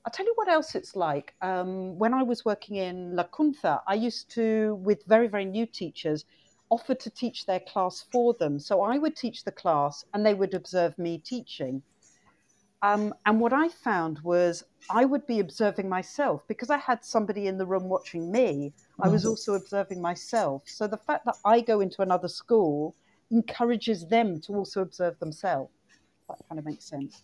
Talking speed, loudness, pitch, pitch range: 195 wpm, -28 LUFS, 205 Hz, 180-230 Hz